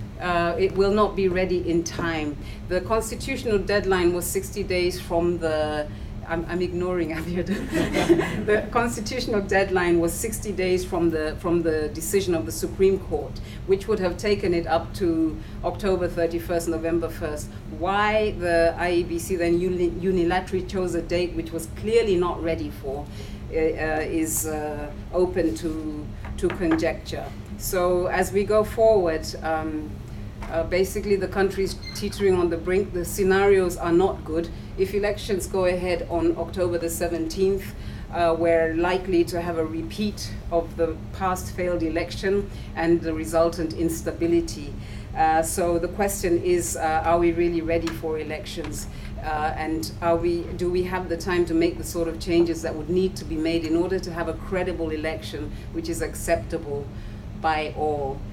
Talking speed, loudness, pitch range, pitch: 160 wpm, -24 LUFS, 160-185 Hz, 170 Hz